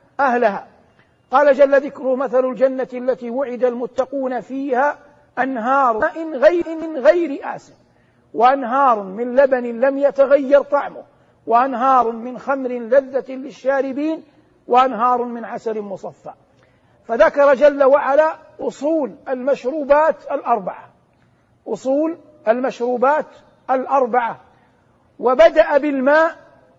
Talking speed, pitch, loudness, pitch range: 95 wpm, 270 Hz, -17 LUFS, 250-285 Hz